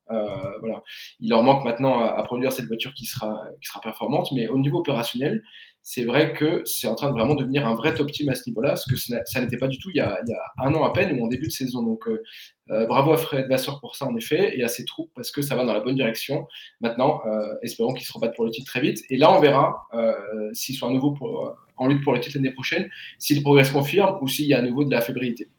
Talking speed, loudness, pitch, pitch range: 280 wpm, -23 LUFS, 130 Hz, 120-145 Hz